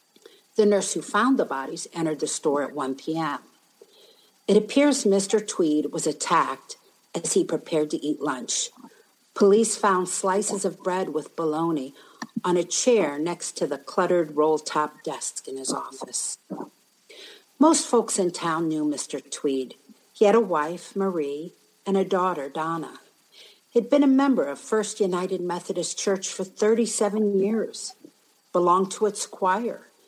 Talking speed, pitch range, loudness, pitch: 150 wpm, 160-225 Hz, -24 LUFS, 195 Hz